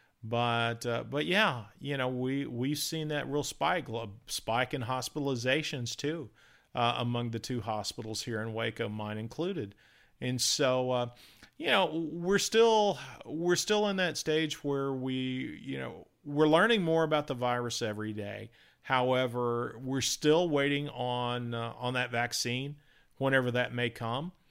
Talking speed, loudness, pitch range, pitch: 155 wpm, -31 LUFS, 120-150 Hz, 130 Hz